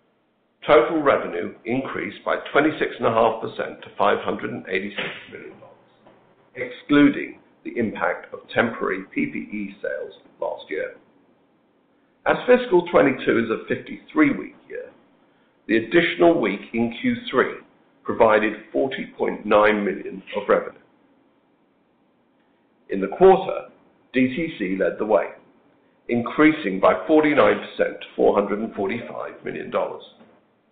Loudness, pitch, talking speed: -22 LUFS, 285 Hz, 90 wpm